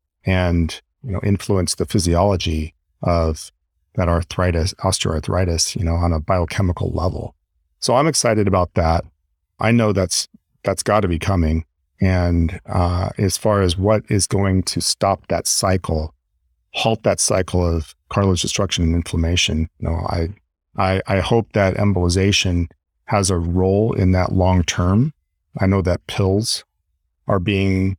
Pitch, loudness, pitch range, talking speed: 90 Hz, -19 LUFS, 85-100 Hz, 150 wpm